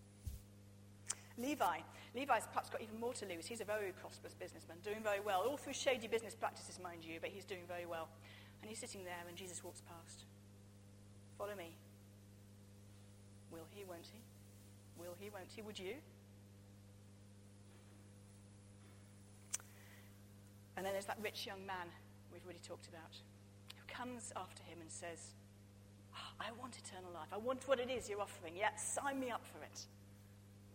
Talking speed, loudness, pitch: 165 wpm, -46 LUFS, 100 Hz